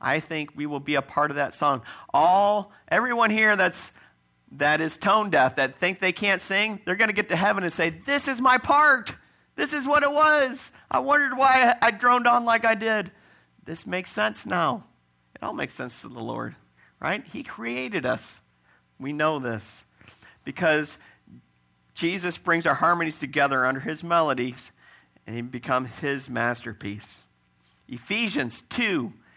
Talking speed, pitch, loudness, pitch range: 170 wpm, 160 Hz, -23 LUFS, 125-215 Hz